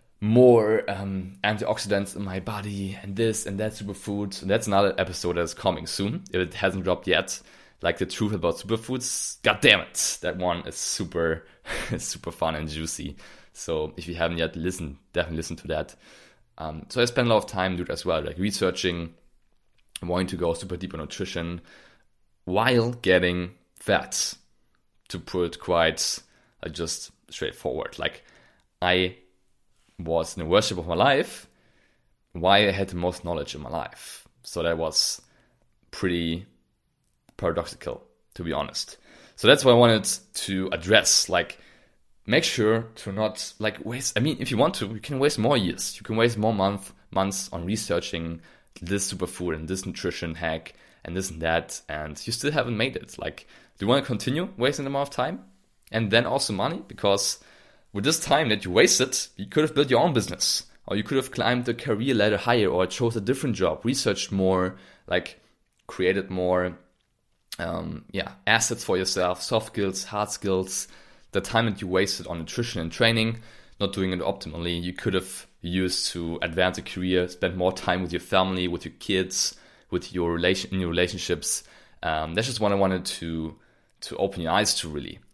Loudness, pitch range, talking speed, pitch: -25 LUFS, 90-110 Hz, 185 wpm, 95 Hz